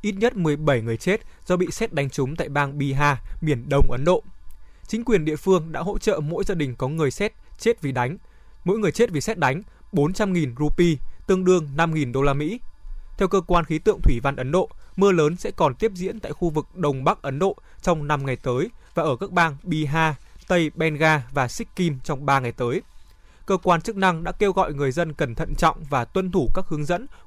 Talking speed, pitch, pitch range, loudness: 230 wpm, 160 Hz, 140-185 Hz, -23 LUFS